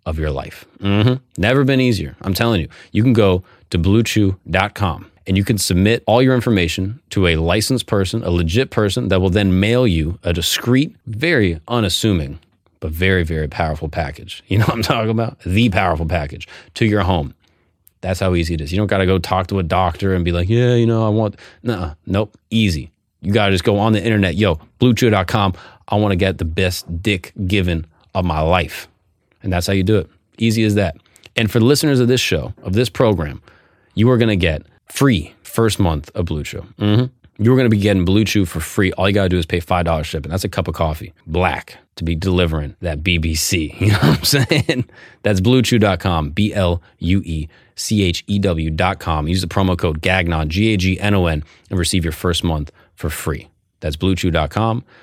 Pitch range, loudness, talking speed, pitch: 85-110 Hz, -17 LUFS, 215 wpm, 95 Hz